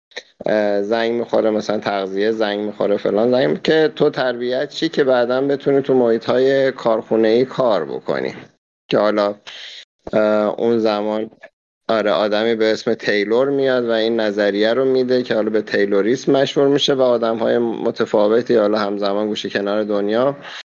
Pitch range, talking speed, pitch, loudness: 105-130 Hz, 150 wpm, 115 Hz, -18 LUFS